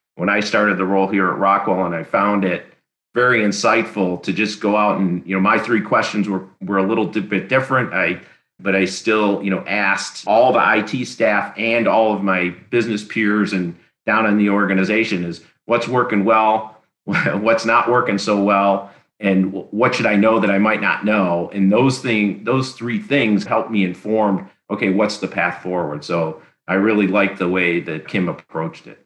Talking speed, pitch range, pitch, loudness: 195 wpm, 95-110 Hz, 100 Hz, -18 LUFS